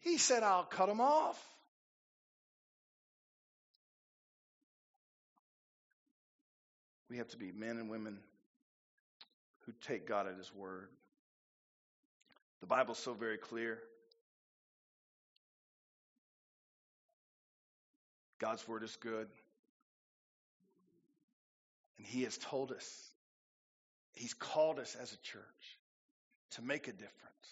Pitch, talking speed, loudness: 155 Hz, 95 wpm, -39 LUFS